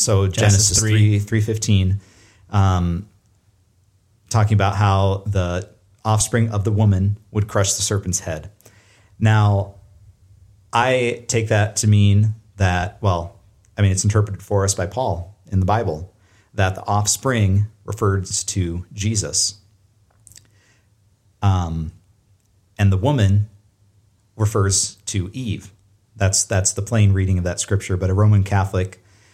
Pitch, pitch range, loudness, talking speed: 100 Hz, 95-105 Hz, -19 LUFS, 130 wpm